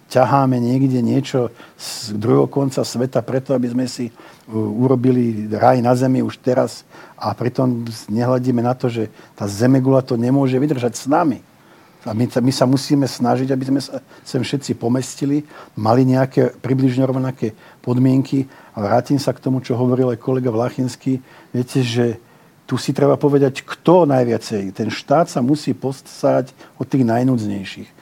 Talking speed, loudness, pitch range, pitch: 155 wpm, -18 LUFS, 120-135 Hz, 130 Hz